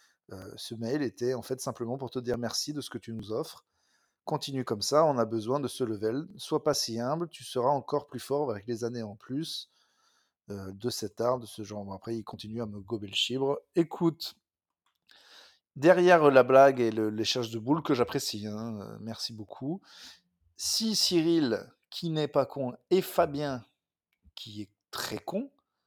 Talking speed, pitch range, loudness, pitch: 195 wpm, 110-145 Hz, -29 LUFS, 125 Hz